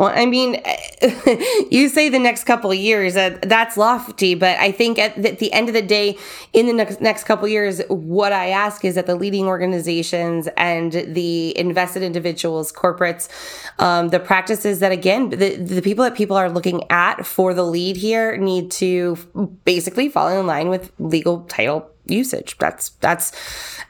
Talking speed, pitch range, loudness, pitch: 180 wpm, 180-220 Hz, -18 LUFS, 190 Hz